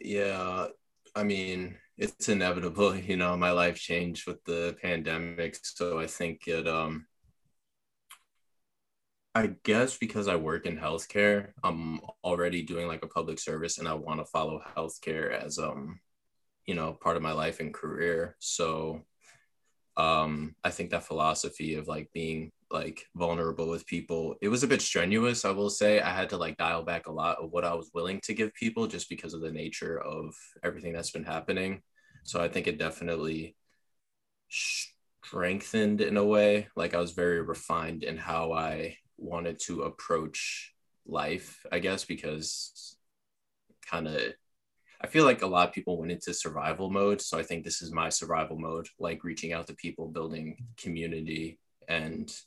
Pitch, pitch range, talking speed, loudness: 85 Hz, 80-90 Hz, 170 wpm, -31 LUFS